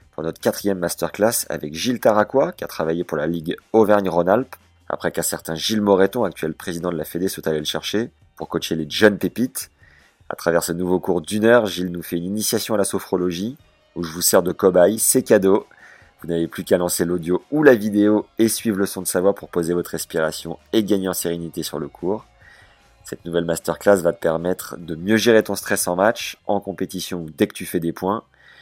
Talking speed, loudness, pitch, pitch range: 220 wpm, -20 LUFS, 90 Hz, 85-100 Hz